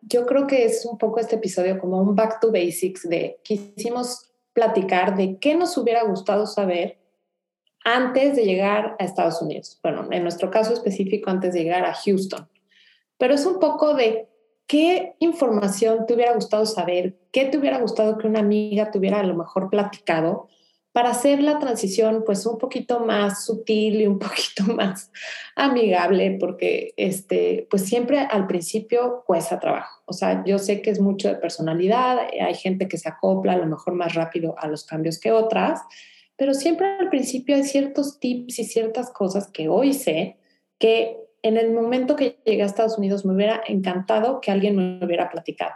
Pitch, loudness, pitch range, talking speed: 220 Hz, -22 LUFS, 190-245 Hz, 180 wpm